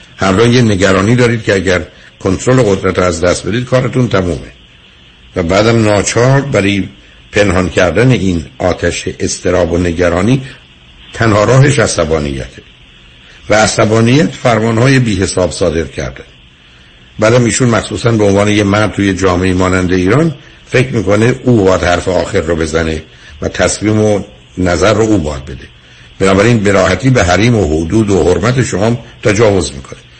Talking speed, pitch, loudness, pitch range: 145 wpm, 95 Hz, -11 LUFS, 85-115 Hz